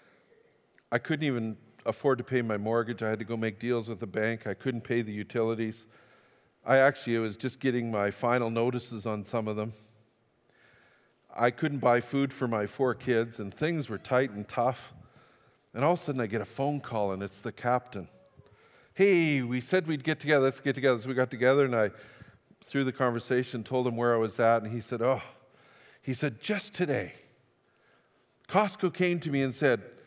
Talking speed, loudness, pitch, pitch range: 200 wpm, -29 LUFS, 120 Hz, 115-135 Hz